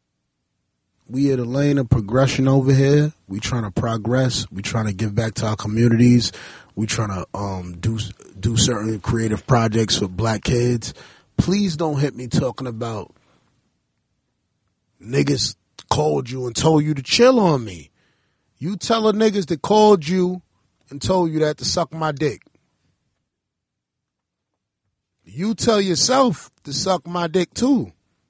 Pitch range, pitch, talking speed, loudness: 110-165 Hz, 130 Hz, 150 wpm, -20 LUFS